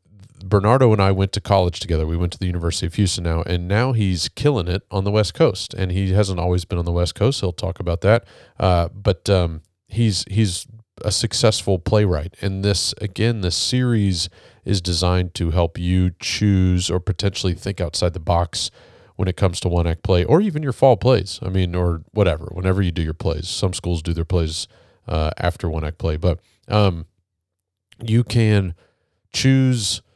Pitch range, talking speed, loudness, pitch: 90-105 Hz, 195 wpm, -20 LUFS, 95 Hz